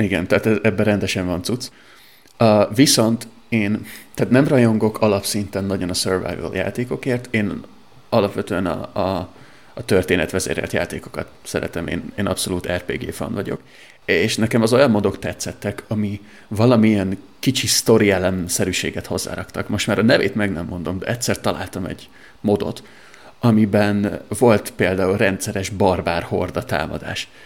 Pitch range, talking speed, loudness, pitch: 95-110 Hz, 135 wpm, -19 LUFS, 105 Hz